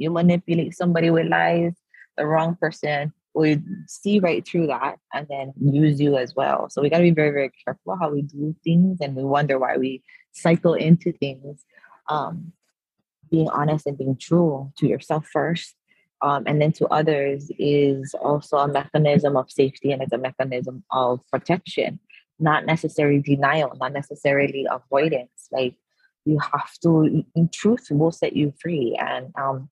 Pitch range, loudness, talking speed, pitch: 140-165 Hz, -22 LUFS, 170 wpm, 150 Hz